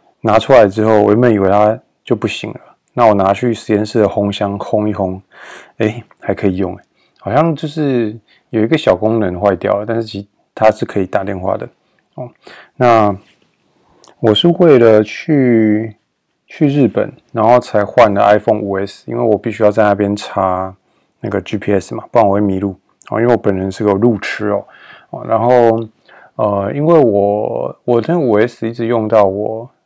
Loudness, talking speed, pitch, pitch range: -13 LUFS, 260 characters per minute, 110 Hz, 100-115 Hz